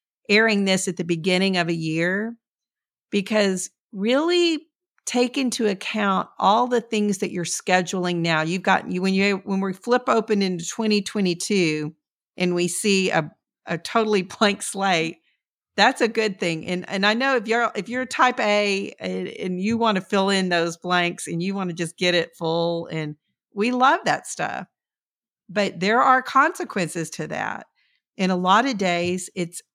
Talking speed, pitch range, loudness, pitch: 175 wpm, 175-225 Hz, -22 LUFS, 195 Hz